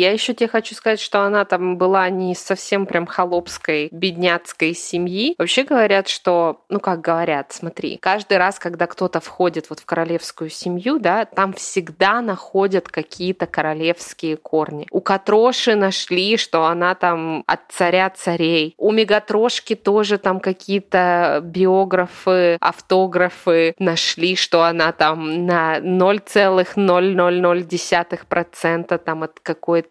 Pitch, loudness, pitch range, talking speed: 180 Hz, -18 LUFS, 170-195 Hz, 125 wpm